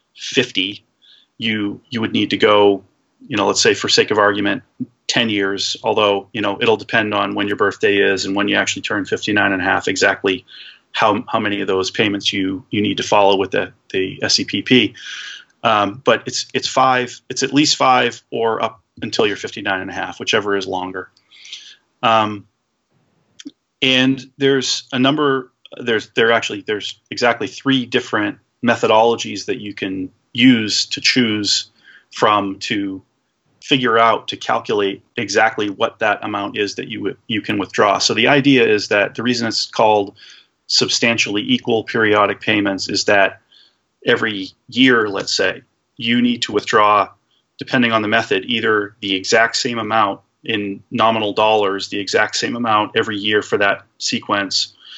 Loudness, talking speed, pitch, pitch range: -17 LUFS, 165 wpm, 110 Hz, 100-125 Hz